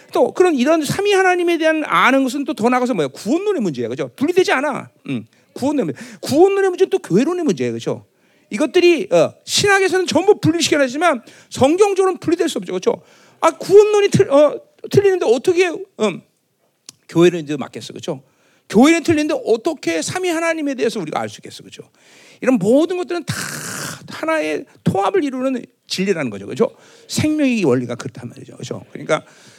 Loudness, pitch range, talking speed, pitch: -17 LUFS, 250-370 Hz, 420 characters per minute, 315 Hz